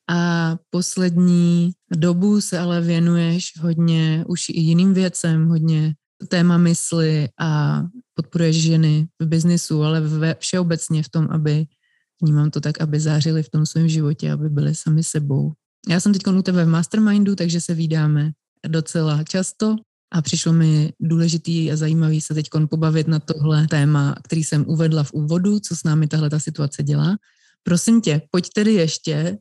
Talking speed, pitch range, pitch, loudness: 160 wpm, 155-175 Hz, 165 Hz, -19 LUFS